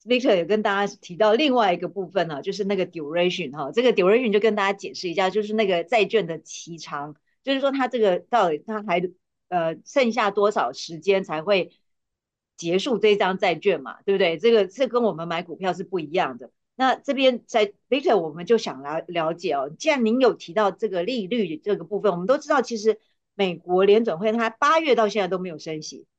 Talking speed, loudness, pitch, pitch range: 360 characters per minute, -23 LUFS, 205 Hz, 175-230 Hz